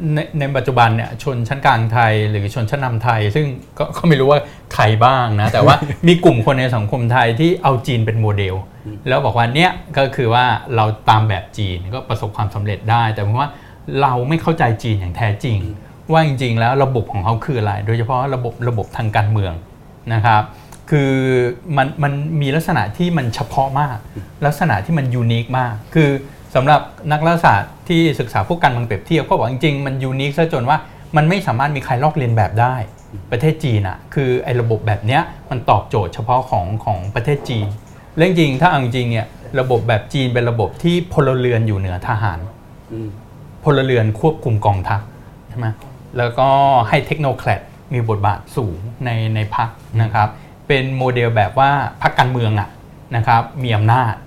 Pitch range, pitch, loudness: 110-140 Hz, 125 Hz, -16 LUFS